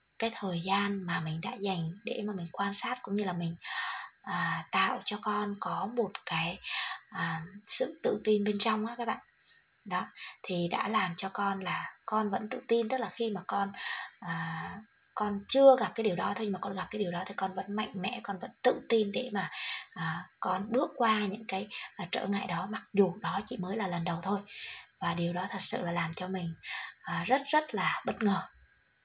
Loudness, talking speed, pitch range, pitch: -31 LUFS, 225 wpm, 185-225 Hz, 200 Hz